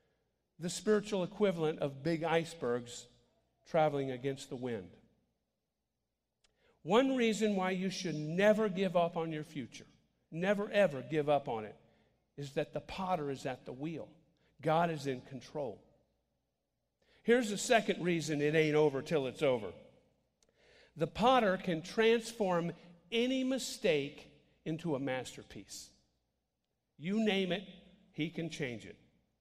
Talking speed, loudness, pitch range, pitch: 135 wpm, -34 LUFS, 145-195 Hz, 165 Hz